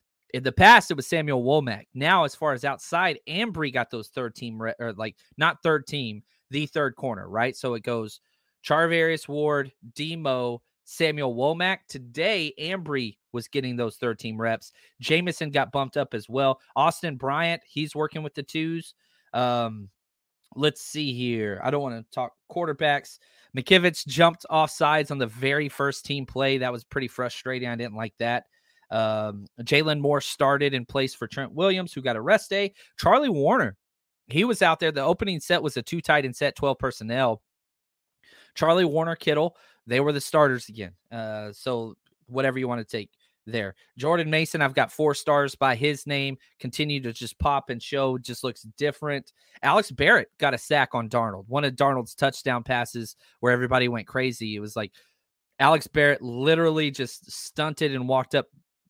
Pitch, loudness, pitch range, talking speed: 135 Hz, -25 LUFS, 120-155 Hz, 180 wpm